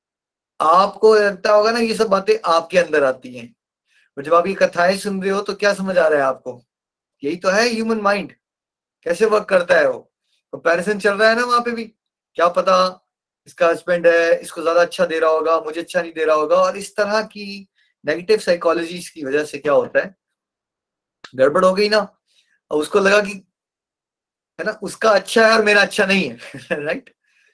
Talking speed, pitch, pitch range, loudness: 200 wpm, 190 Hz, 165-215 Hz, -17 LUFS